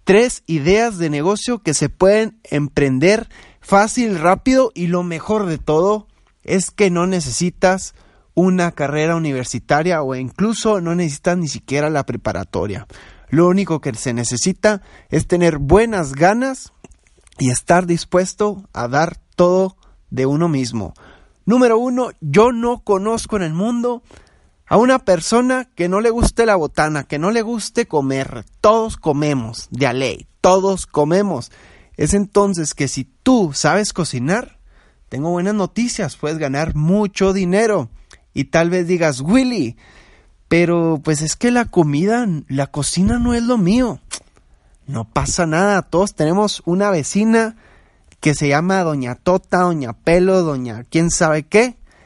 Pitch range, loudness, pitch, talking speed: 145-205 Hz, -17 LUFS, 175 Hz, 145 wpm